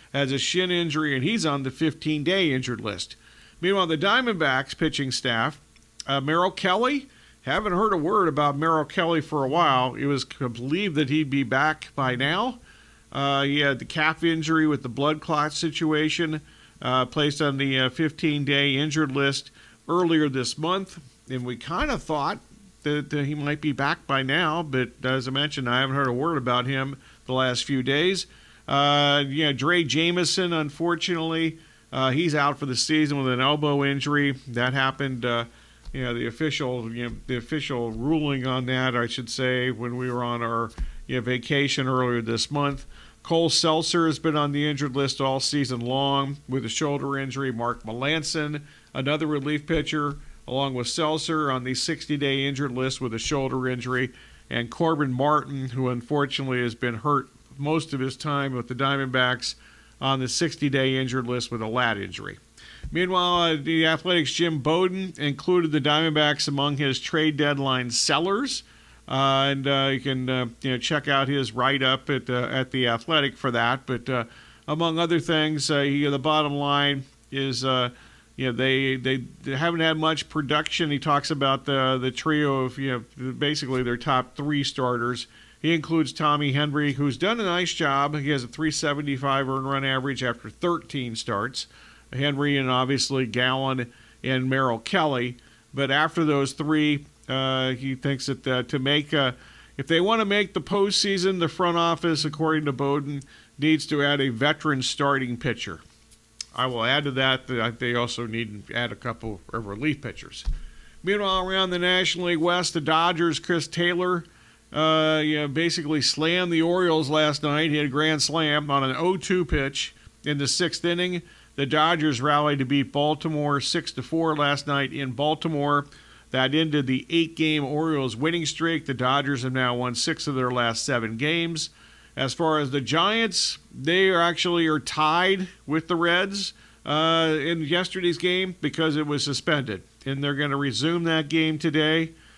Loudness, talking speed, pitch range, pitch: -24 LUFS, 175 wpm, 130-160 Hz, 145 Hz